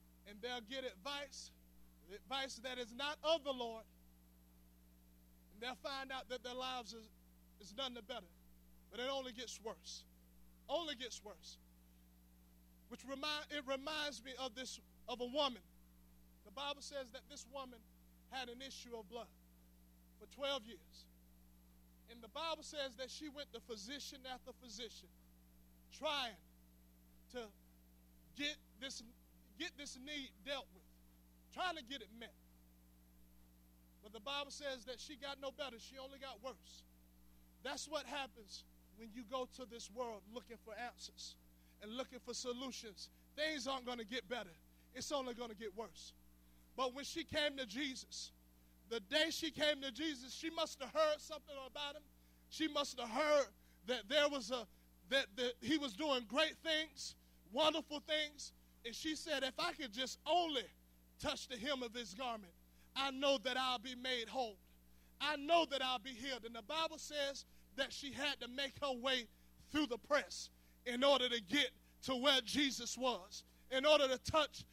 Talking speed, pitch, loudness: 165 wpm, 245 Hz, -42 LUFS